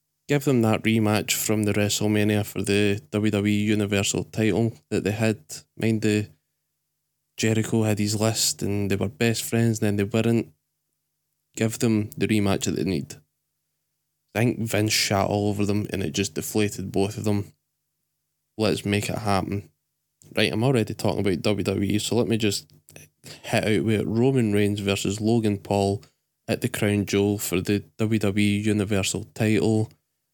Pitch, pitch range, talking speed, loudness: 105 Hz, 95-110 Hz, 165 wpm, -24 LUFS